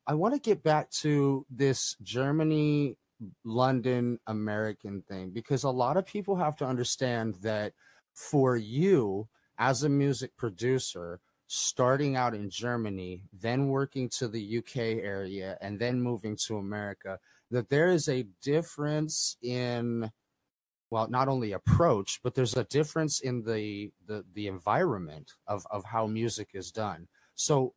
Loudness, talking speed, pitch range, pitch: -30 LUFS, 145 wpm, 105-135 Hz, 120 Hz